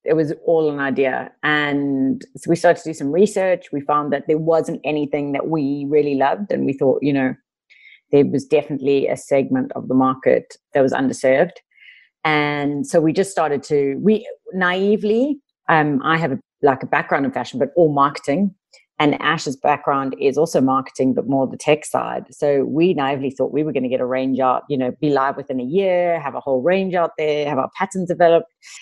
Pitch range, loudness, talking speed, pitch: 135-165 Hz, -19 LUFS, 205 wpm, 145 Hz